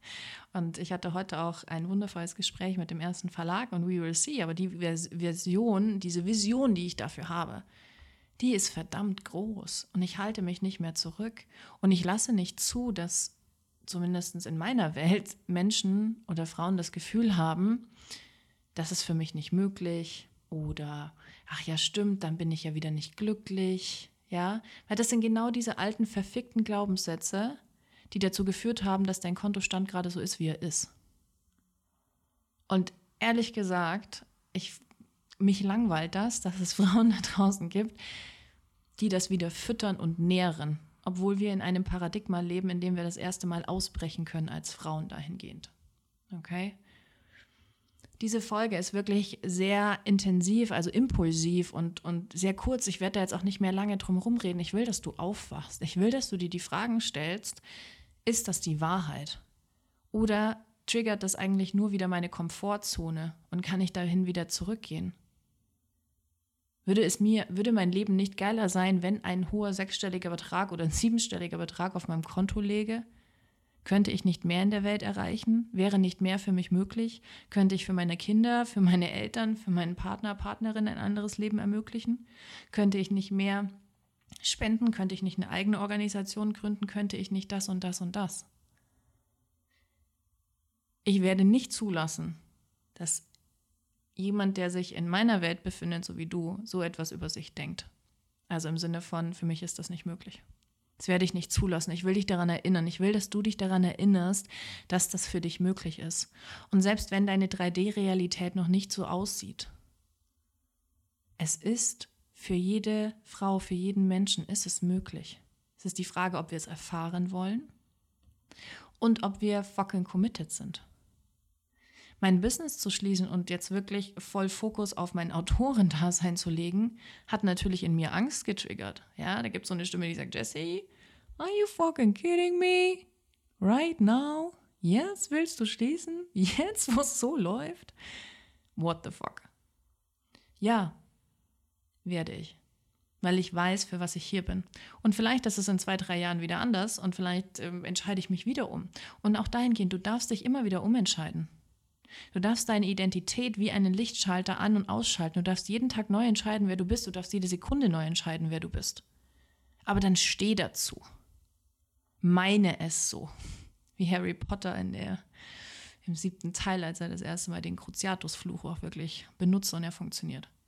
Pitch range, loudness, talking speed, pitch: 170-205 Hz, -31 LUFS, 170 wpm, 185 Hz